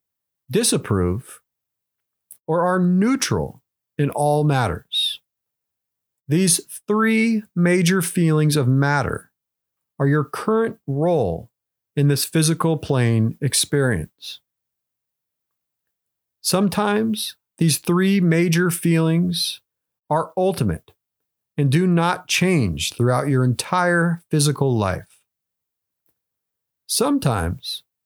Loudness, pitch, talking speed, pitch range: -20 LUFS, 160 Hz, 85 wpm, 135-180 Hz